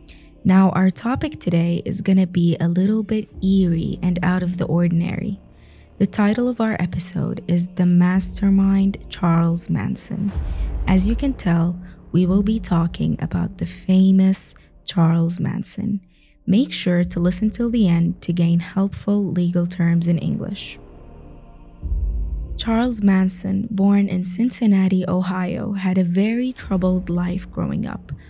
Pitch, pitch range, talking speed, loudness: 185 Hz, 170-195 Hz, 140 wpm, -20 LUFS